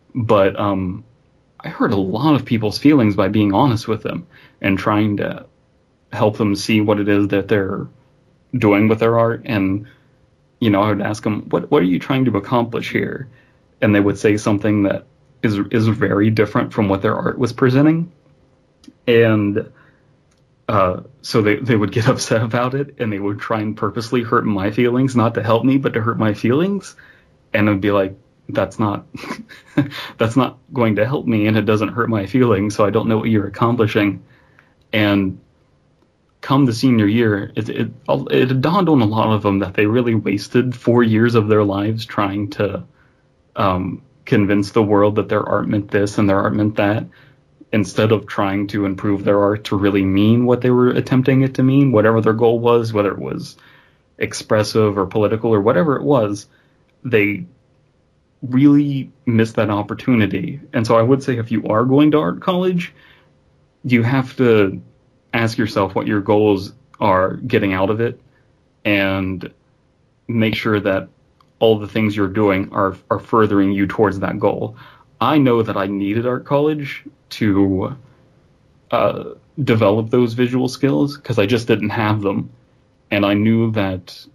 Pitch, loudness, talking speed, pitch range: 110 Hz, -17 LUFS, 180 wpm, 105-125 Hz